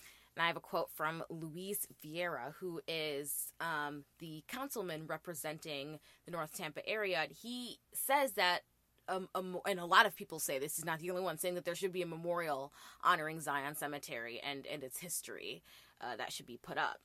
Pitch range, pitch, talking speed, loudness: 150-180 Hz, 165 Hz, 195 wpm, -38 LUFS